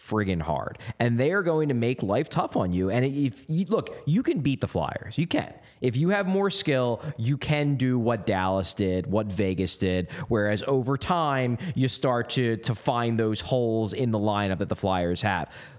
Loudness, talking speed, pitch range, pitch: -26 LUFS, 200 wpm, 105-140 Hz, 120 Hz